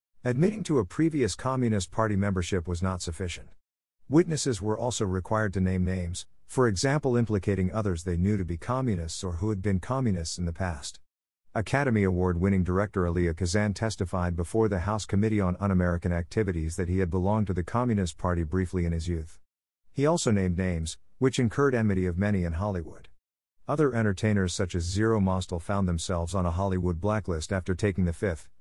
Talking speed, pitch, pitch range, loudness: 185 wpm, 95 Hz, 90-110 Hz, -28 LUFS